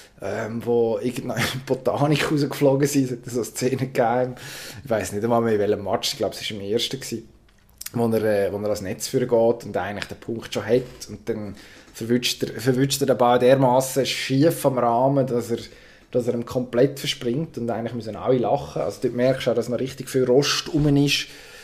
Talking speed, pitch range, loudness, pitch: 210 wpm, 115-130 Hz, -22 LUFS, 125 Hz